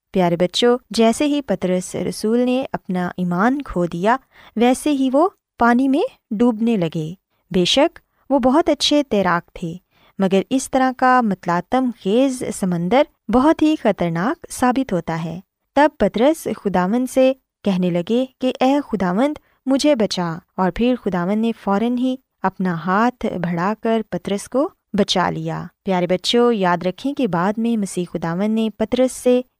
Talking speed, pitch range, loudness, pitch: 150 wpm, 185-260 Hz, -19 LUFS, 225 Hz